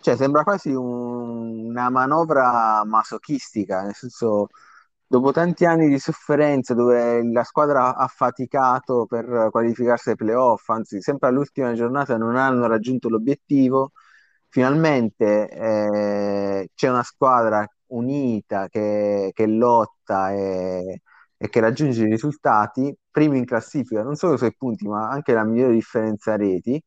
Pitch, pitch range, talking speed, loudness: 120 Hz, 110-135 Hz, 135 wpm, -21 LUFS